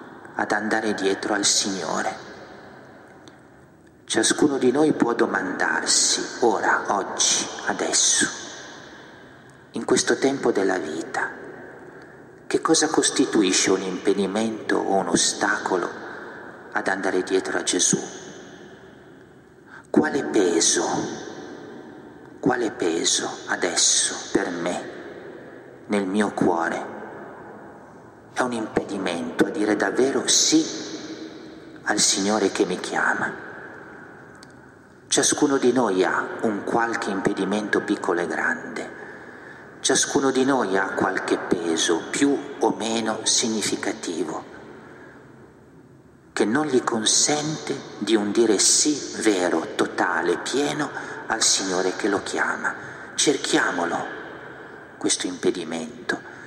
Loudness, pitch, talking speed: -22 LUFS, 160 Hz, 100 wpm